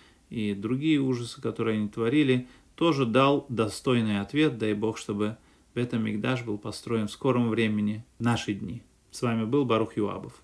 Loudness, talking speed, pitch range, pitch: -27 LUFS, 160 wpm, 105-130 Hz, 115 Hz